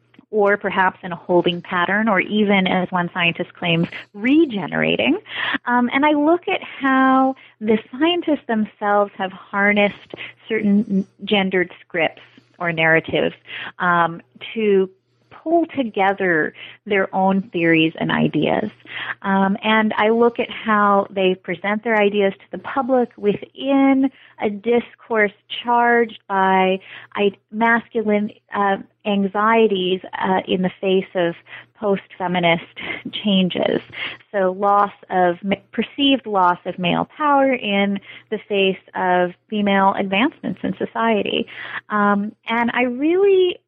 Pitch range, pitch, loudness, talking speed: 190-235 Hz, 205 Hz, -19 LUFS, 120 wpm